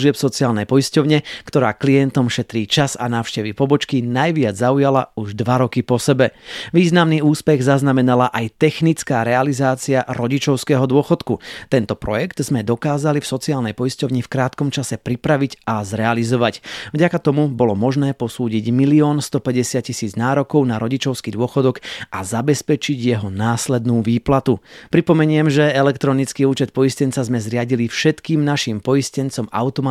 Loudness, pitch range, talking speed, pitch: -18 LUFS, 120-145 Hz, 130 wpm, 130 Hz